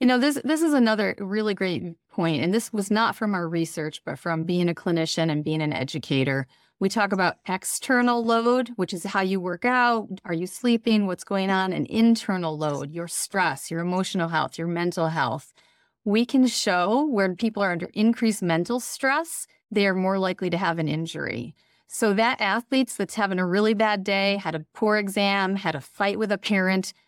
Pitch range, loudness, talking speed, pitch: 170-225 Hz, -24 LUFS, 200 wpm, 195 Hz